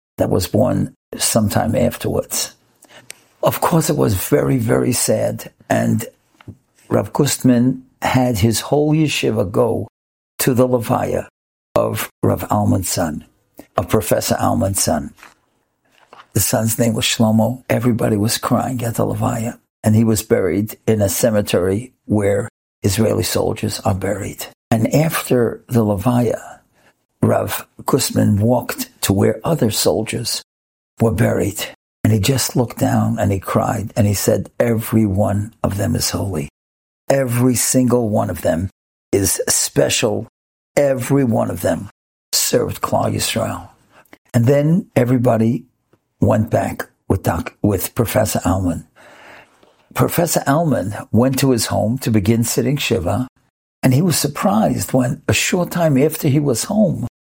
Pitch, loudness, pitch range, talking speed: 115 Hz, -17 LUFS, 105-130 Hz, 135 wpm